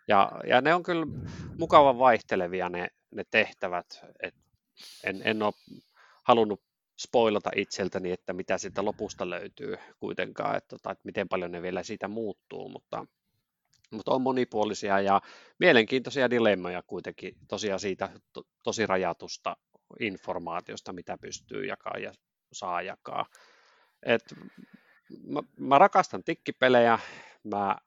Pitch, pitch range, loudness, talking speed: 110 Hz, 95-130 Hz, -28 LUFS, 125 wpm